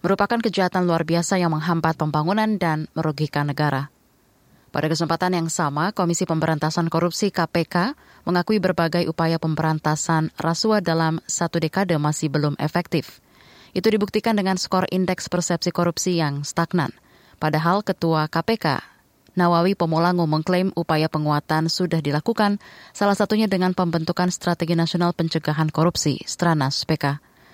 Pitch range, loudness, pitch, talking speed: 155-180 Hz, -22 LUFS, 170 Hz, 125 wpm